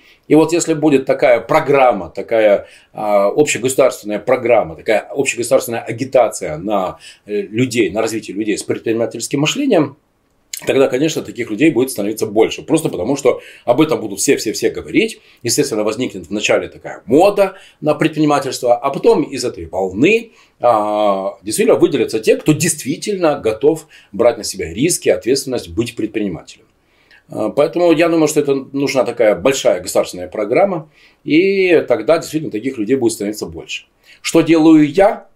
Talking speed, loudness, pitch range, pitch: 140 wpm, -15 LUFS, 115-175 Hz, 150 Hz